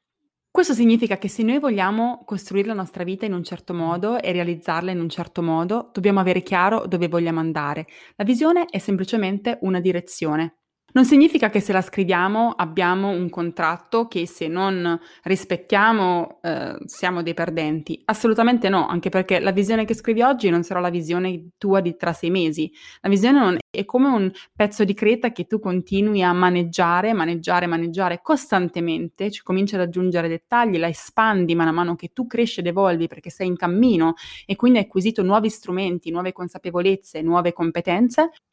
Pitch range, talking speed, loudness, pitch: 175-215 Hz, 175 wpm, -21 LUFS, 185 Hz